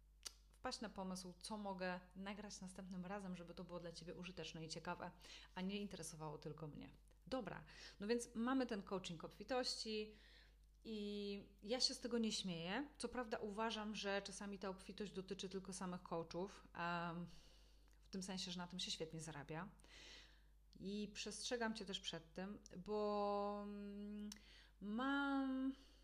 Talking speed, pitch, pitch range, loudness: 145 wpm, 200 Hz, 175-215 Hz, -48 LUFS